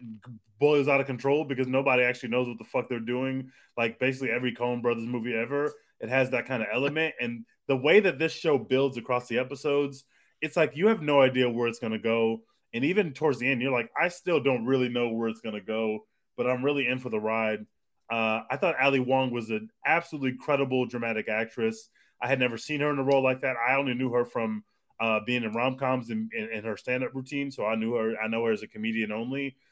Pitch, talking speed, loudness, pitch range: 125 Hz, 240 wpm, -28 LUFS, 115-140 Hz